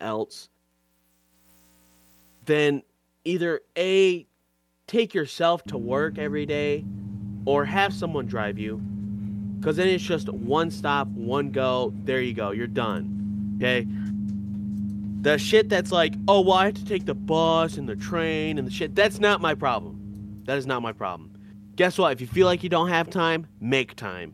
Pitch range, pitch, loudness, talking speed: 100-170 Hz, 120 Hz, -25 LUFS, 170 wpm